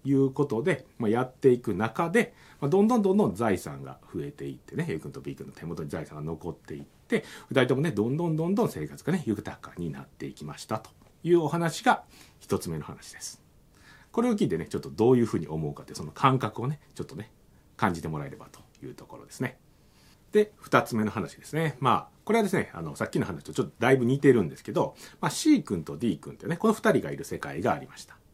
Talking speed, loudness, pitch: 435 characters per minute, -28 LUFS, 135 Hz